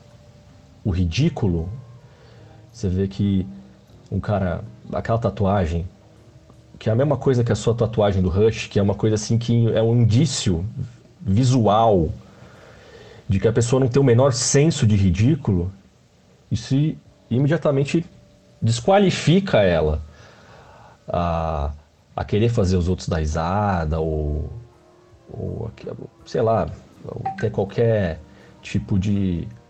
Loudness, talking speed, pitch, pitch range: -21 LUFS, 125 wpm, 110 Hz, 95-120 Hz